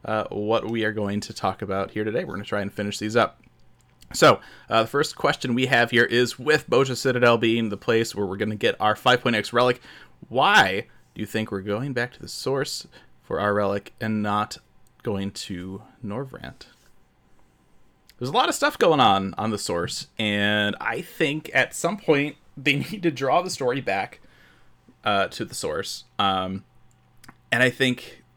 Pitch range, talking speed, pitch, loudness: 105-125 Hz, 190 wpm, 110 Hz, -23 LUFS